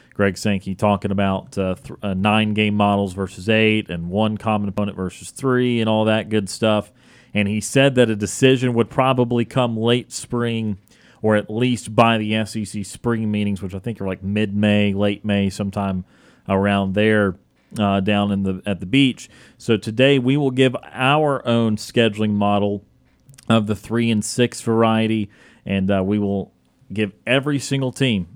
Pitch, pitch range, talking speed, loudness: 105 Hz, 100-120 Hz, 180 wpm, -20 LUFS